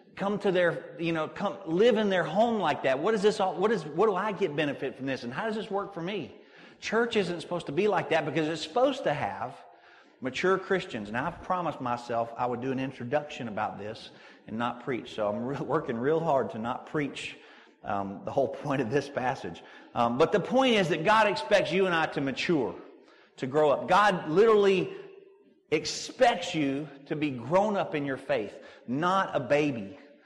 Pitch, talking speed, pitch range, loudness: 175 Hz, 210 wpm, 145-205 Hz, -28 LUFS